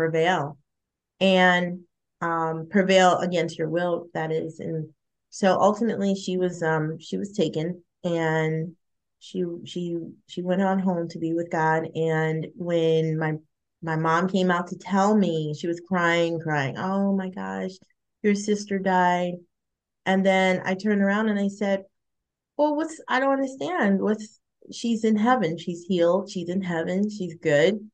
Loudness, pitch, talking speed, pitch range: -24 LUFS, 175 Hz, 155 wpm, 160-195 Hz